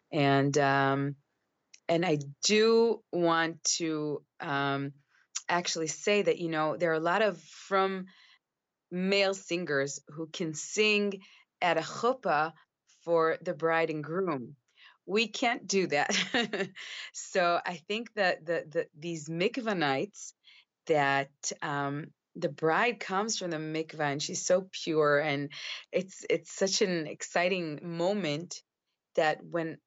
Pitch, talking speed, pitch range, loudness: 170 Hz, 135 wpm, 155-195 Hz, -30 LUFS